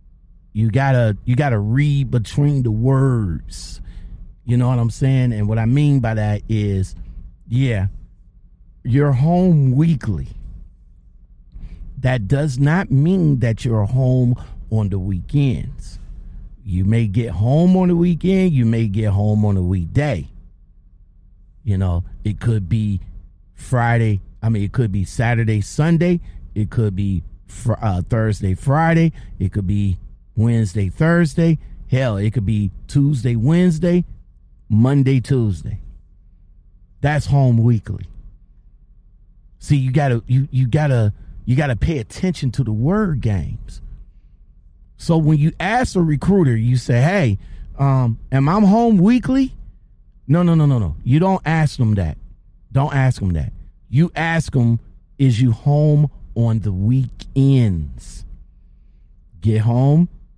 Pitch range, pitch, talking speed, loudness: 95-140 Hz, 115 Hz, 135 wpm, -18 LUFS